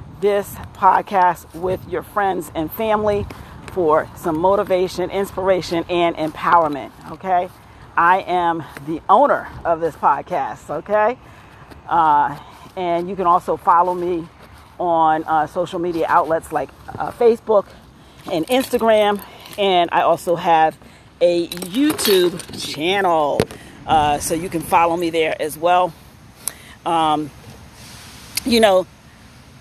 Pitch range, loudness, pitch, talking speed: 160-195 Hz, -18 LUFS, 175 Hz, 120 wpm